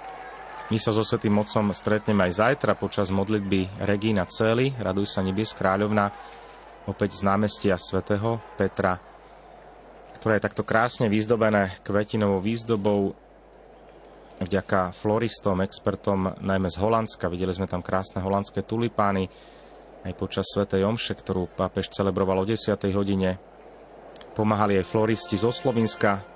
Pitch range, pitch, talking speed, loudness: 95-110 Hz, 100 Hz, 125 wpm, -25 LUFS